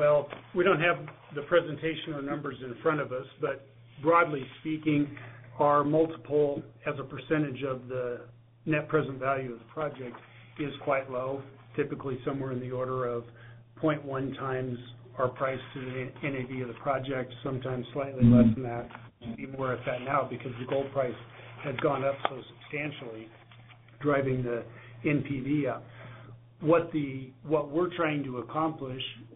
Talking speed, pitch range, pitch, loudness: 160 wpm, 120-145 Hz, 135 Hz, -30 LUFS